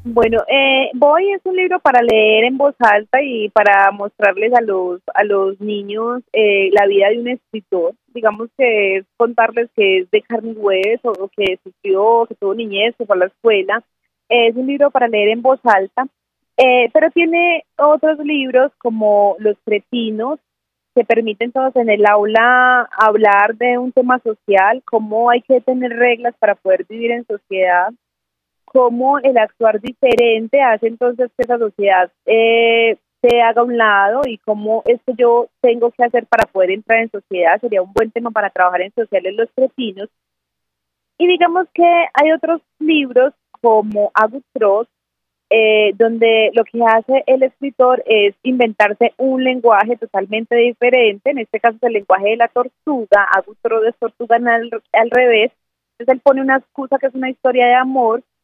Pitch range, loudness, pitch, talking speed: 210-255 Hz, -14 LUFS, 230 Hz, 170 wpm